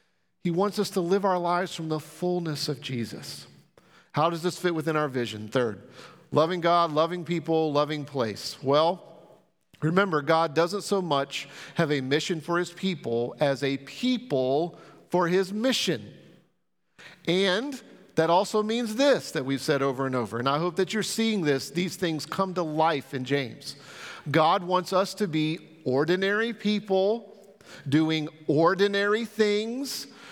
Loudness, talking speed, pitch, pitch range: -26 LUFS, 155 wpm, 170 Hz, 145-195 Hz